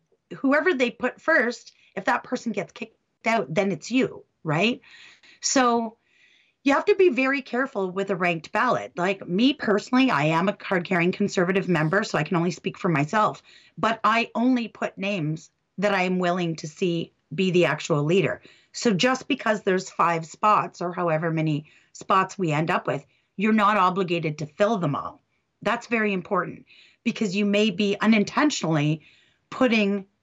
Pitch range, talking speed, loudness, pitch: 175-230 Hz, 175 wpm, -24 LUFS, 200 Hz